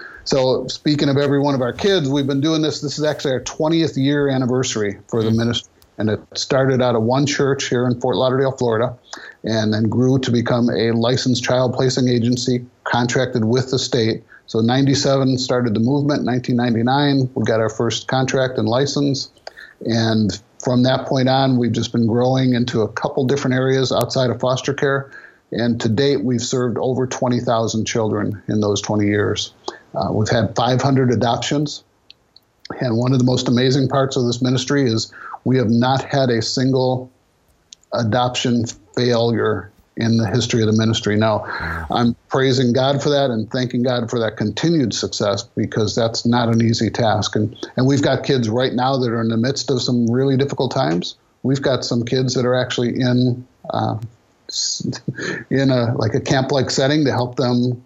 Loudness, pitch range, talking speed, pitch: -18 LUFS, 115-135 Hz, 185 wpm, 125 Hz